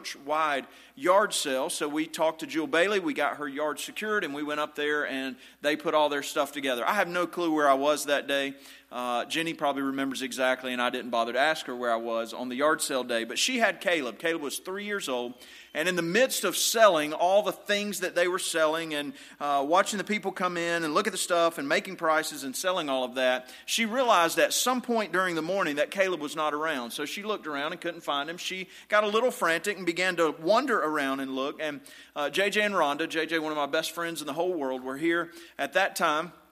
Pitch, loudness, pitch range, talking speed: 160 Hz, -27 LUFS, 140-185 Hz, 245 wpm